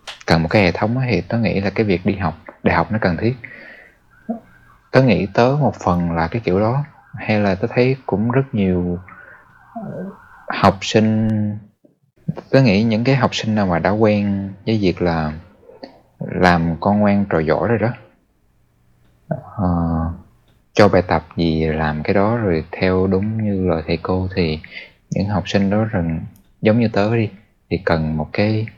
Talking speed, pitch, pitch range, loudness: 175 wpm, 100 Hz, 85-110 Hz, -18 LUFS